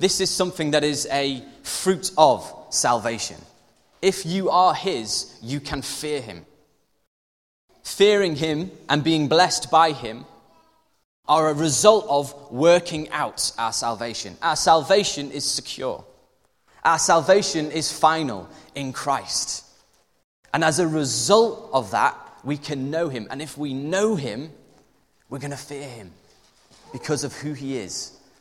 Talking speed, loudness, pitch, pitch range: 140 wpm, -22 LUFS, 150 Hz, 135-165 Hz